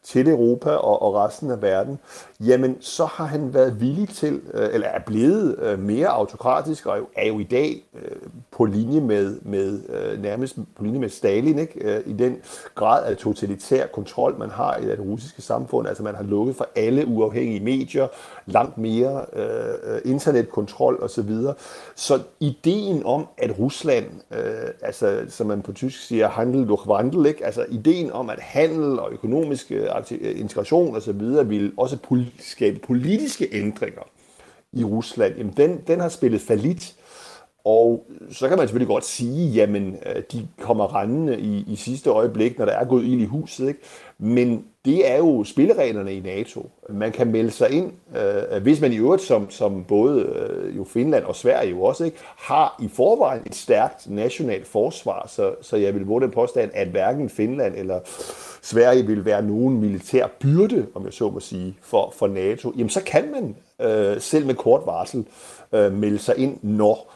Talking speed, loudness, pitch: 175 wpm, -22 LUFS, 130 Hz